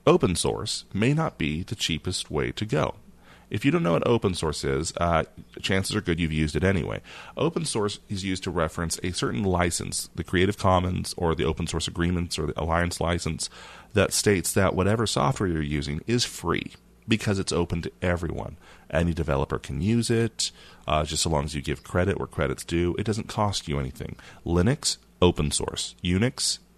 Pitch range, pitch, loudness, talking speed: 80-100 Hz, 85 Hz, -26 LUFS, 195 wpm